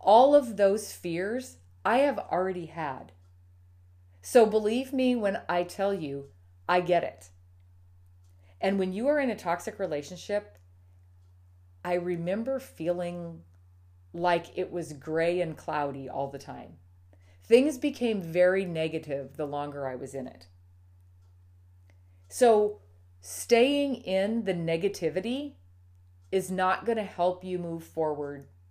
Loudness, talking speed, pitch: -28 LUFS, 130 wpm, 160 Hz